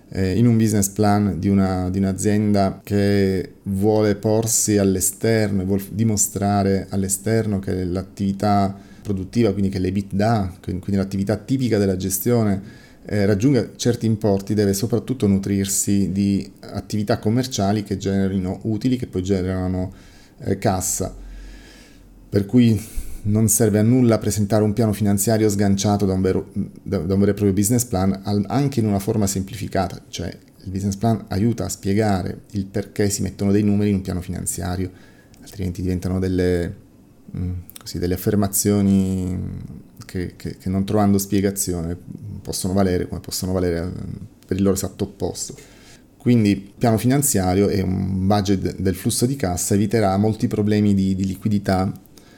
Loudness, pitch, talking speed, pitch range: -20 LUFS, 100 Hz, 145 wpm, 95-105 Hz